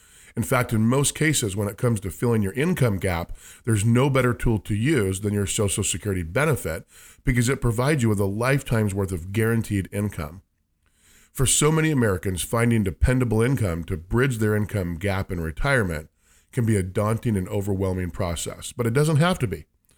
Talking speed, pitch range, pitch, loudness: 185 wpm, 95-125 Hz, 105 Hz, -23 LUFS